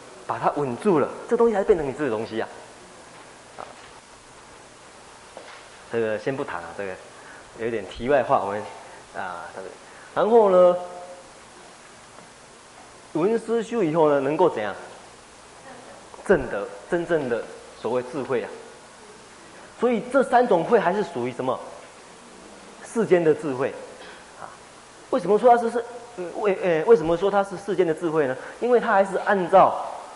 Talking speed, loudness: 210 characters per minute, -23 LUFS